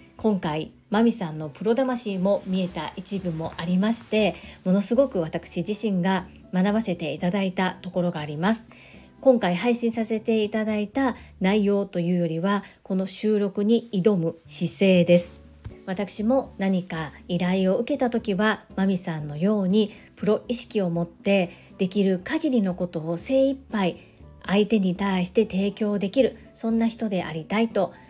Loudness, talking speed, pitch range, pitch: -24 LUFS, 300 characters per minute, 180-220 Hz, 195 Hz